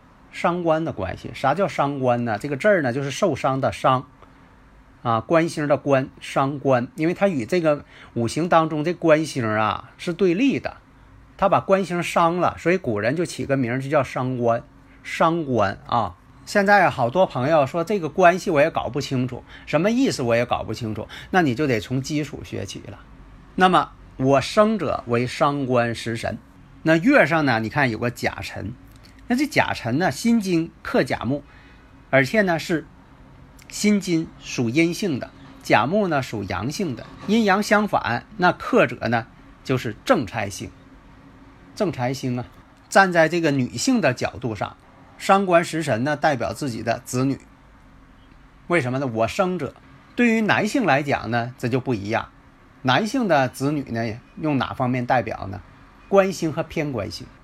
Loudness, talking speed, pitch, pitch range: -22 LUFS, 240 characters per minute, 140 Hz, 120-170 Hz